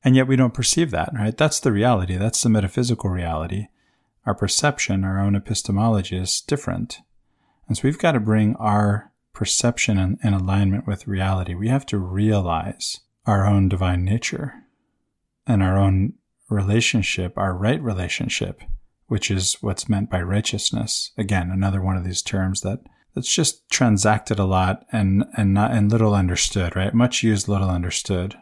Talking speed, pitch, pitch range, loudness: 165 wpm, 105 Hz, 95-115 Hz, -21 LUFS